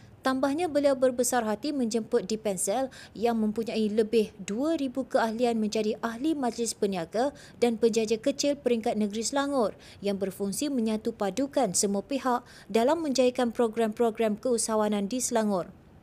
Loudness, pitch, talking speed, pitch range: -28 LUFS, 235 Hz, 125 wpm, 215-260 Hz